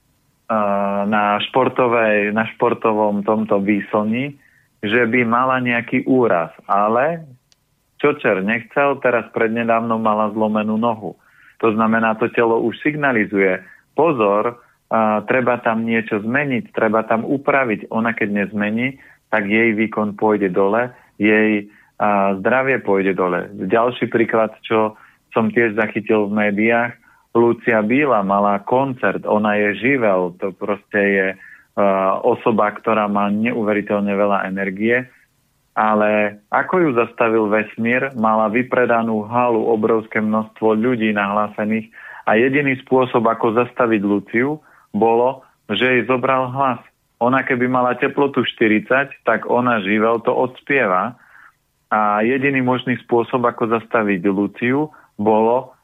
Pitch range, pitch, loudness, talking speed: 105-125 Hz, 115 Hz, -18 LUFS, 120 wpm